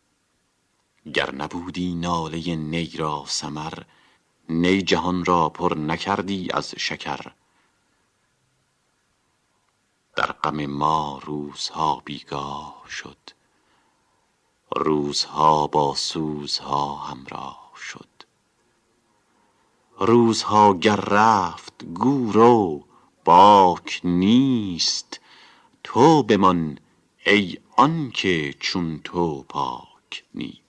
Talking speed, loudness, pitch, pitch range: 75 wpm, -21 LUFS, 90 Hz, 75-105 Hz